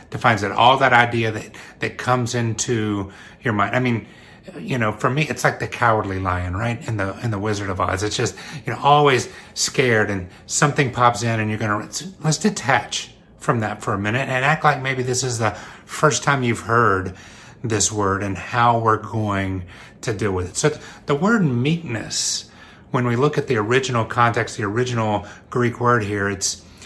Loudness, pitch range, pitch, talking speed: -20 LUFS, 105-125 Hz, 115 Hz, 195 wpm